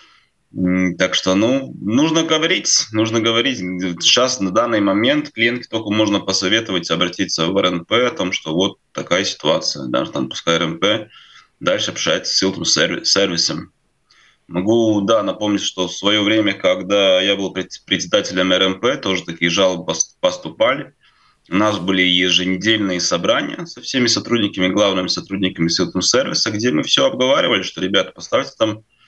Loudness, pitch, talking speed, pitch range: -17 LUFS, 95 Hz, 145 wpm, 90-110 Hz